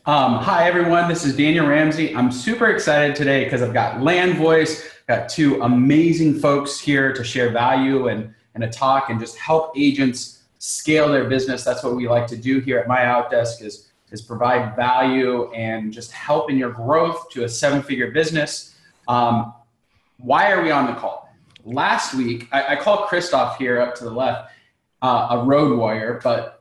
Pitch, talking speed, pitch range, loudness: 130 Hz, 185 wpm, 120-150 Hz, -19 LUFS